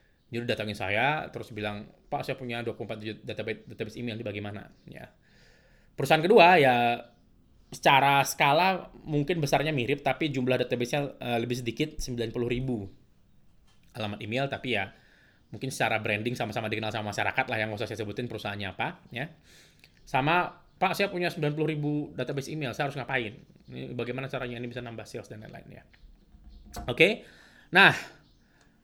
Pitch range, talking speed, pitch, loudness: 110-140 Hz, 160 wpm, 120 Hz, -28 LUFS